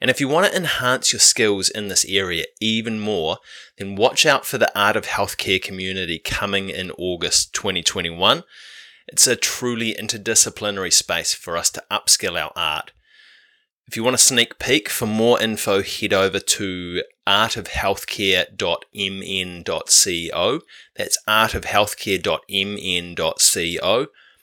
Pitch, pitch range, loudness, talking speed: 100 Hz, 95-115 Hz, -19 LUFS, 130 wpm